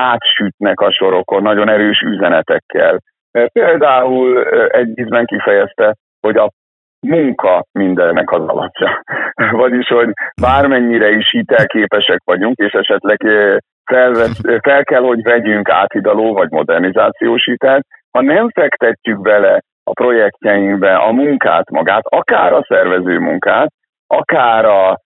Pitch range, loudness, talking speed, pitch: 105-130 Hz, -12 LUFS, 115 wpm, 120 Hz